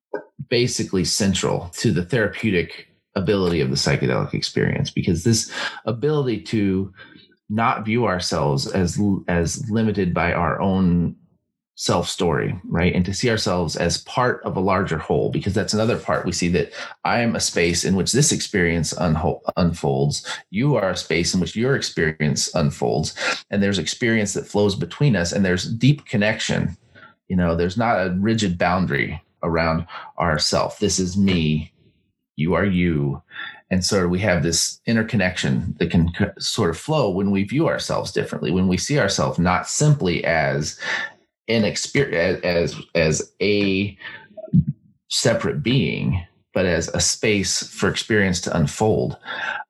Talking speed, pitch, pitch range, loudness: 150 wpm, 95 Hz, 85-110 Hz, -21 LUFS